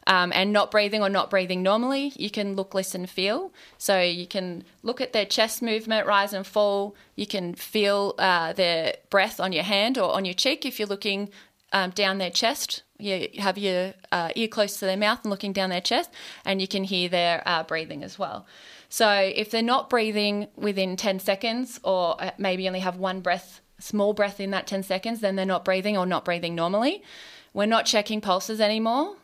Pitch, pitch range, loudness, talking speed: 200 Hz, 185-215 Hz, -25 LUFS, 205 wpm